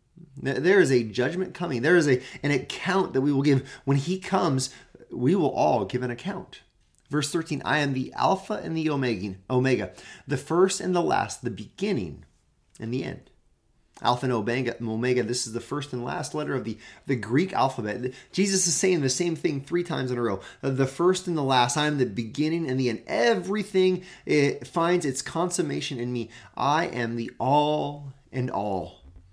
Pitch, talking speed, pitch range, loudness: 135 Hz, 190 wpm, 125-170 Hz, -26 LUFS